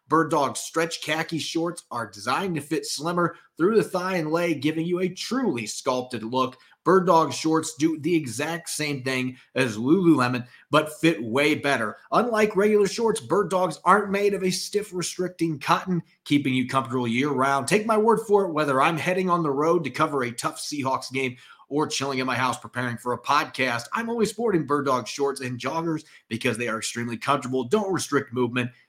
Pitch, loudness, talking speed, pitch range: 155 Hz, -24 LUFS, 195 wpm, 130-175 Hz